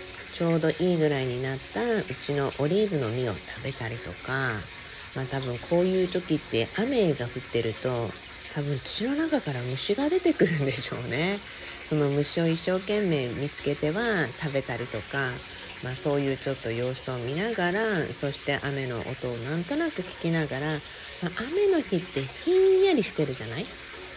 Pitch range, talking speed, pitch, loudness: 130-185 Hz, 350 characters per minute, 145 Hz, -28 LUFS